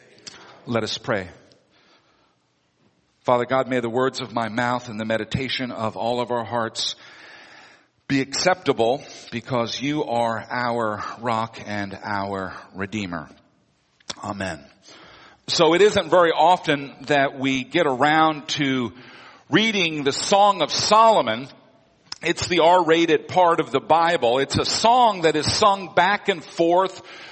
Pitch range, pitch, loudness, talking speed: 115-170 Hz, 135 Hz, -21 LUFS, 135 wpm